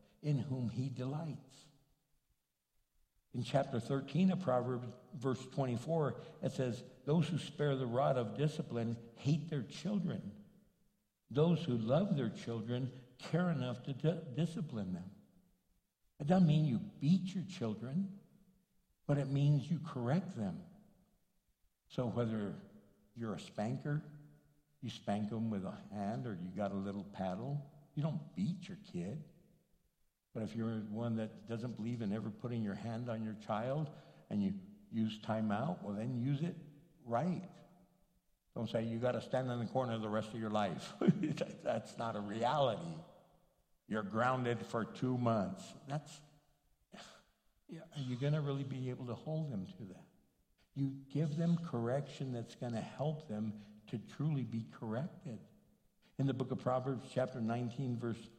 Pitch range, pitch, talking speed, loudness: 115-160 Hz, 135 Hz, 155 wpm, -39 LUFS